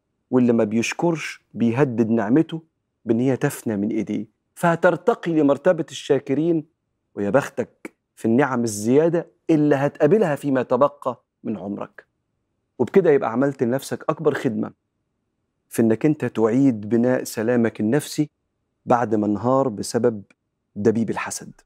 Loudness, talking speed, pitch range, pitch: -21 LUFS, 120 wpm, 115-150 Hz, 125 Hz